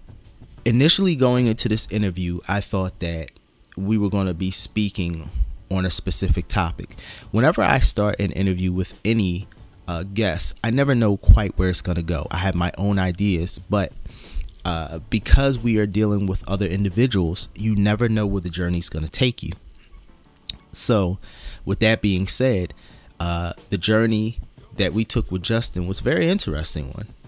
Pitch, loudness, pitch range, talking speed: 95 Hz, -20 LUFS, 85-110 Hz, 175 wpm